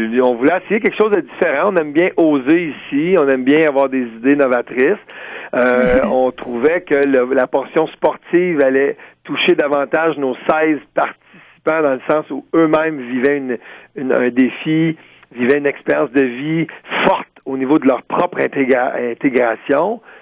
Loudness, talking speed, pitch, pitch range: -16 LUFS, 165 wpm, 140 Hz, 130-160 Hz